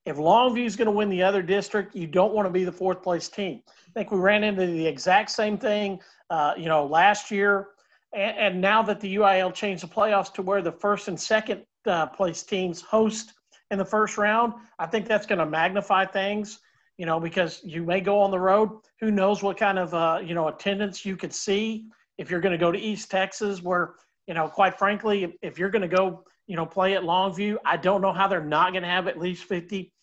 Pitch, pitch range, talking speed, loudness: 195 Hz, 180-210 Hz, 240 wpm, -25 LUFS